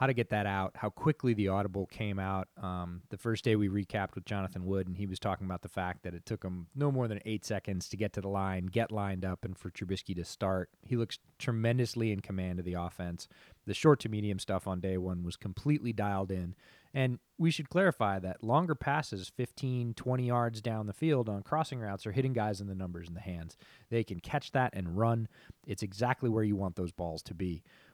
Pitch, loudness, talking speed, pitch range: 100 Hz, -34 LUFS, 230 wpm, 95-120 Hz